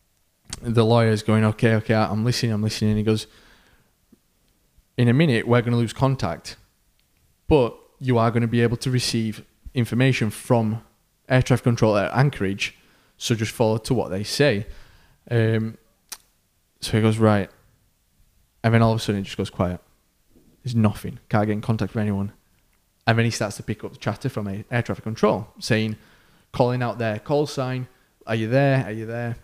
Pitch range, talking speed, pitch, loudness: 105-120 Hz, 190 wpm, 110 Hz, -22 LUFS